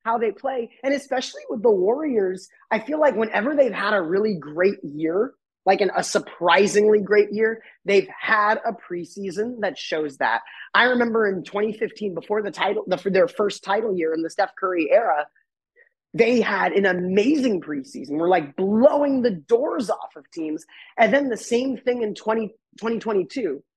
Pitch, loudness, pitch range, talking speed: 215 Hz, -22 LUFS, 190-245 Hz, 175 wpm